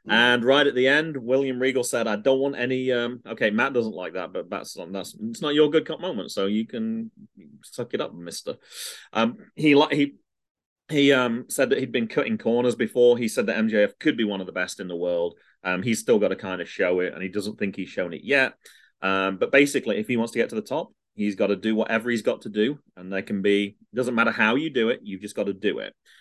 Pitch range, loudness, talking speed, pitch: 105-140 Hz, -24 LUFS, 265 wpm, 120 Hz